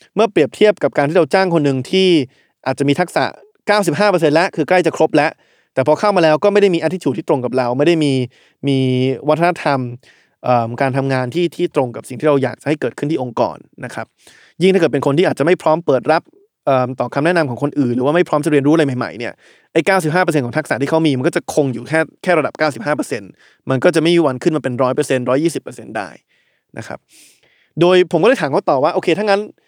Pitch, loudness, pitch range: 155 Hz, -16 LUFS, 135-175 Hz